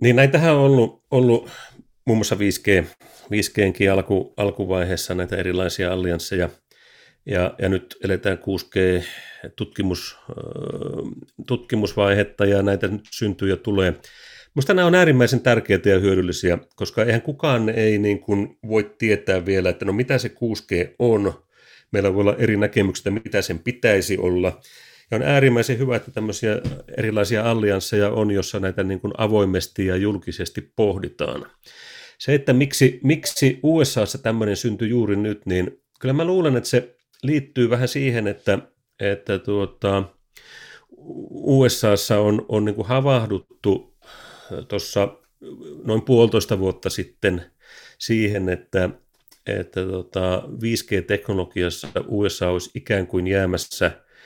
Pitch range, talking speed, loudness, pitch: 95-120 Hz, 130 wpm, -21 LUFS, 105 Hz